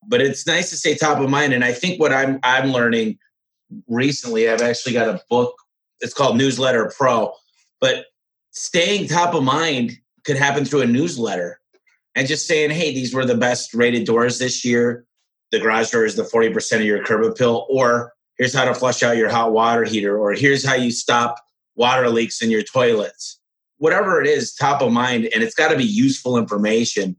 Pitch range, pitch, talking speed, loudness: 115-145 Hz, 125 Hz, 200 wpm, -18 LUFS